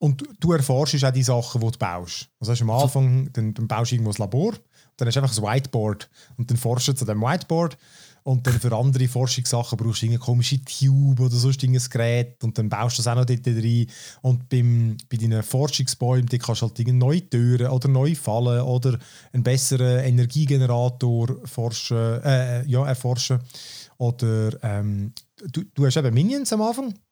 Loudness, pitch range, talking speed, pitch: -22 LUFS, 120-135 Hz, 195 wpm, 125 Hz